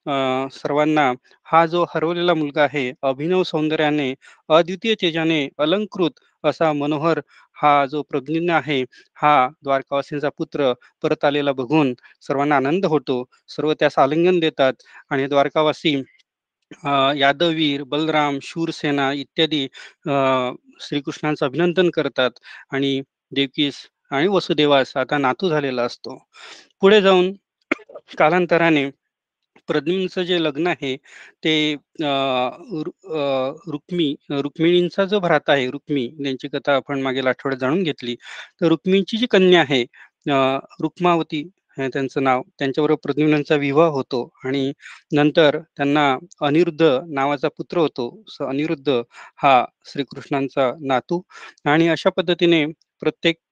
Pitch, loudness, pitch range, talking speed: 150 Hz, -20 LUFS, 140-165 Hz, 110 wpm